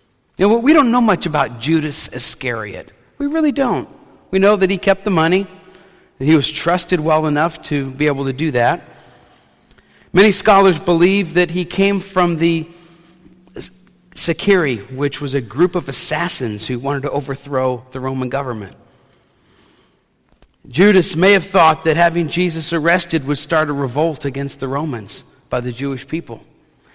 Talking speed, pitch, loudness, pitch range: 160 wpm, 160 Hz, -16 LUFS, 140-185 Hz